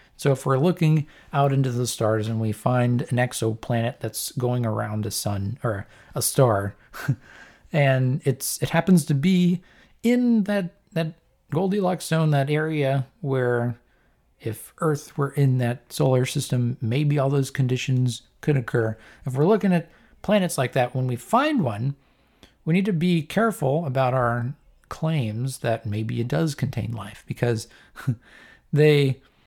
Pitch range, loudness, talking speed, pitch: 120-155 Hz, -24 LUFS, 155 wpm, 135 Hz